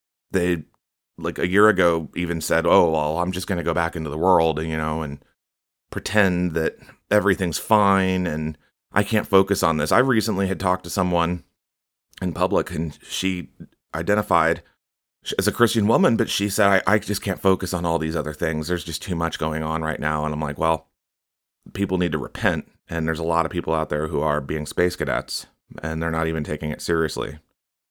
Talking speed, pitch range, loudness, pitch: 205 wpm, 80-95 Hz, -22 LUFS, 85 Hz